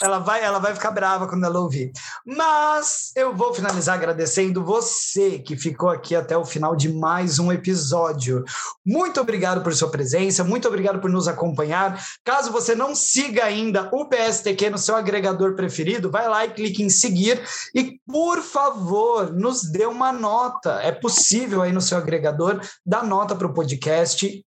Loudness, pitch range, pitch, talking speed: -21 LUFS, 175-235 Hz, 195 Hz, 170 wpm